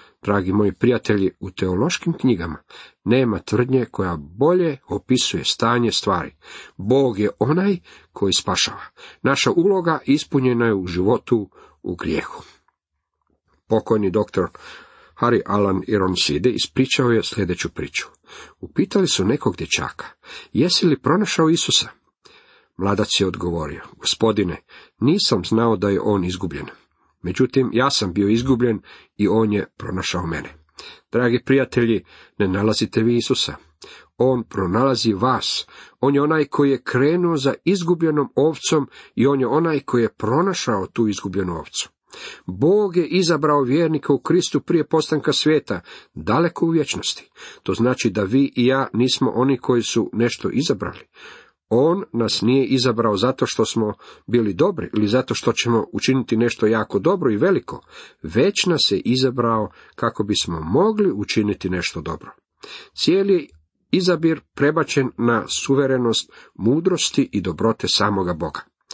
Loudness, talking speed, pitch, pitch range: -20 LUFS, 135 wpm, 120 Hz, 100-140 Hz